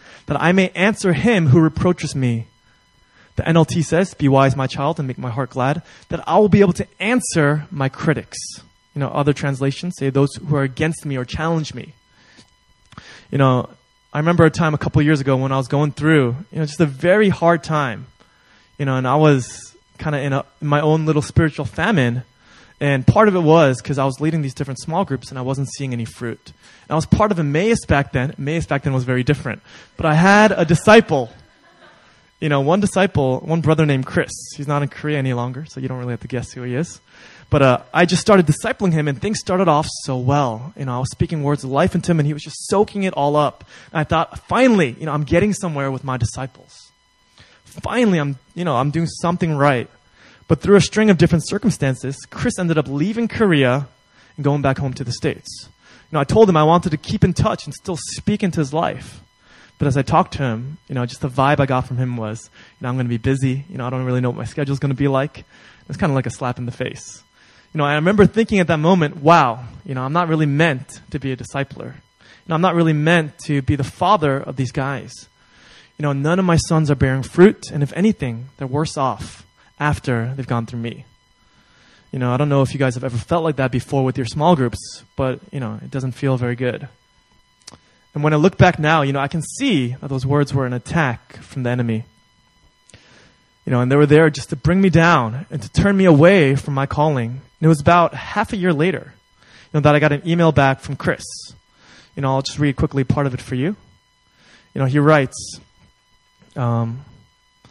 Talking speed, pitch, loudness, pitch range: 235 wpm, 145 Hz, -18 LUFS, 130-165 Hz